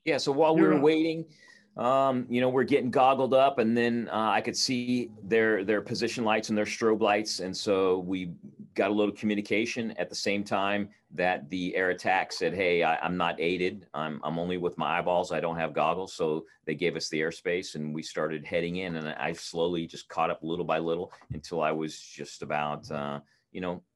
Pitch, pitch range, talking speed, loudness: 95 Hz, 80-115 Hz, 215 wpm, -28 LUFS